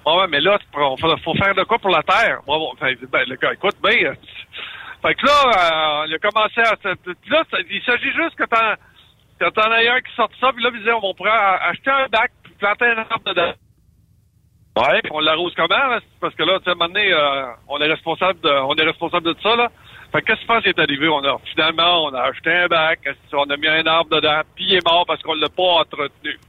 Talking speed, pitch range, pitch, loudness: 240 wpm, 150-210 Hz, 170 Hz, -17 LUFS